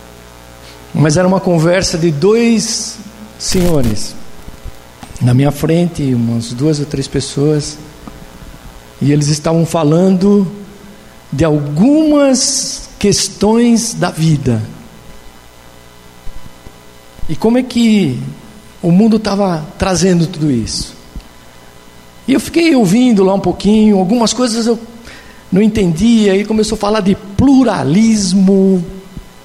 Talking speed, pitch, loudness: 105 wpm, 175 Hz, -12 LUFS